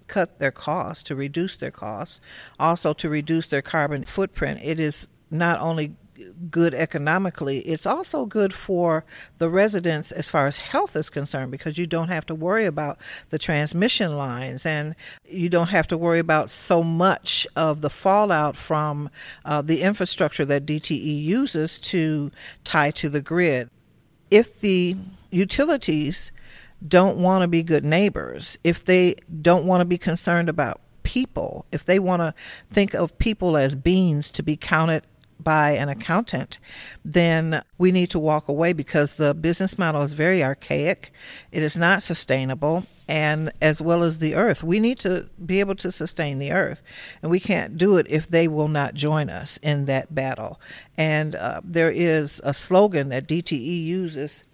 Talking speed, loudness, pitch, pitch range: 170 wpm, -22 LUFS, 160 Hz, 150-180 Hz